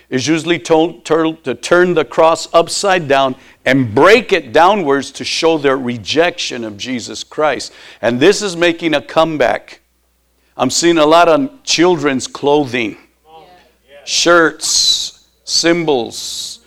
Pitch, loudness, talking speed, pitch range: 160 Hz, -13 LUFS, 125 wpm, 130-170 Hz